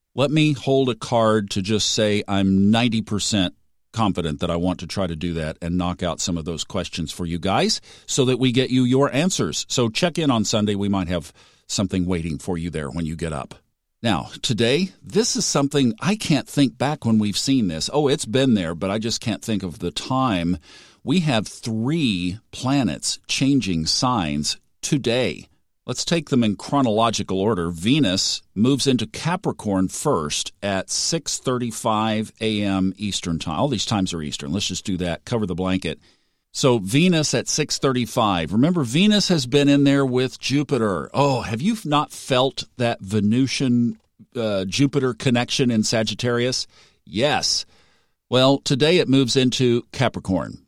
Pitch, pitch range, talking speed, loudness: 110 Hz, 95-135 Hz, 170 wpm, -21 LUFS